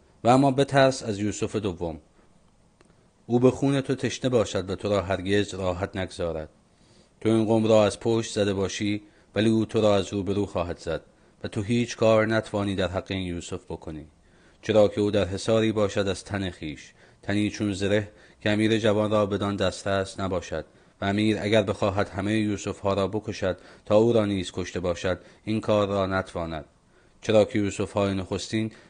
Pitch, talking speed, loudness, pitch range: 100 Hz, 185 wpm, -25 LUFS, 95-110 Hz